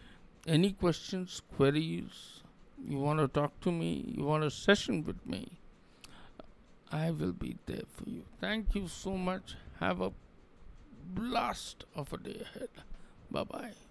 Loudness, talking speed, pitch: -35 LUFS, 145 wpm, 155 Hz